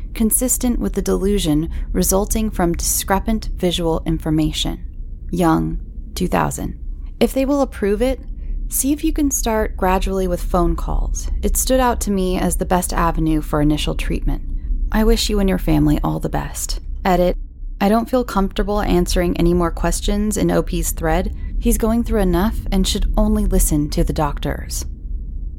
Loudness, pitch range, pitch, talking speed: -19 LUFS, 150-210 Hz, 180 Hz, 160 wpm